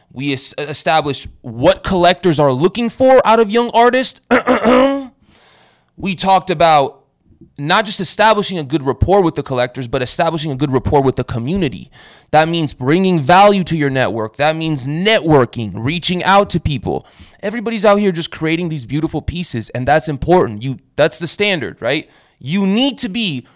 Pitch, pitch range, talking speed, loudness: 165 Hz, 140-200 Hz, 165 wpm, -15 LUFS